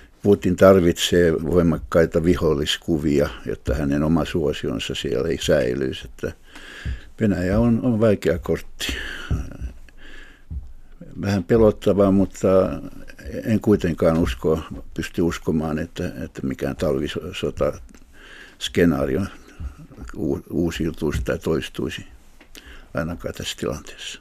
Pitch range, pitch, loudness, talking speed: 80-100 Hz, 85 Hz, -21 LUFS, 85 wpm